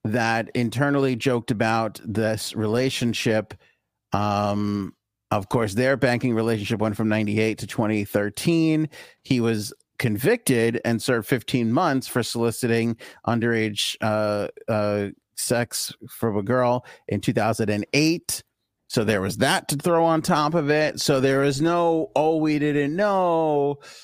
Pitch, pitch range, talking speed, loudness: 115 Hz, 110-140 Hz, 140 wpm, -23 LUFS